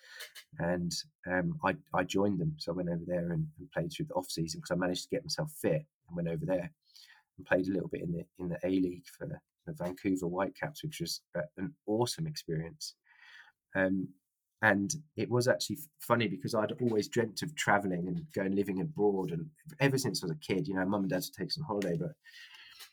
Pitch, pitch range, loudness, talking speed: 105 Hz, 95-155 Hz, -34 LUFS, 205 wpm